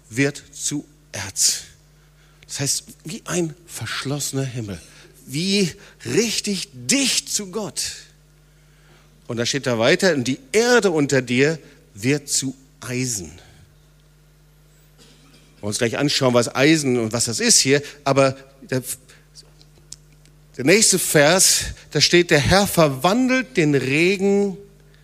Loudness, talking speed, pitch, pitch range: -19 LUFS, 115 wpm, 150 Hz, 135-160 Hz